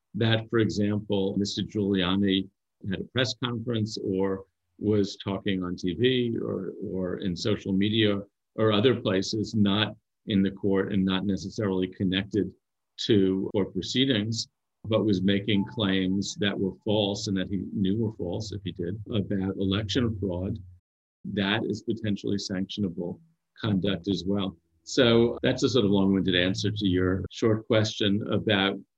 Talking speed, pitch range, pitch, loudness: 145 wpm, 95-110 Hz, 100 Hz, -27 LUFS